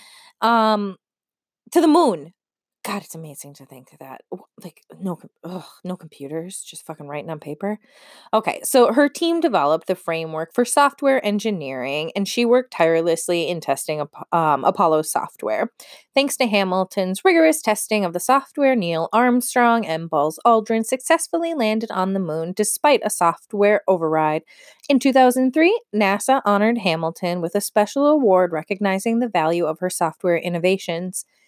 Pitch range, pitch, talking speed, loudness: 165-250 Hz, 200 Hz, 150 wpm, -19 LUFS